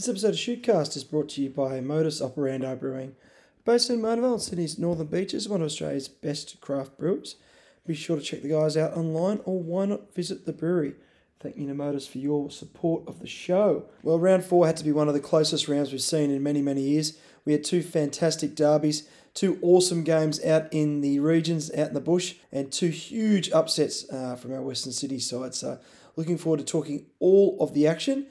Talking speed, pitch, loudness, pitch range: 210 wpm, 155 Hz, -26 LUFS, 145-175 Hz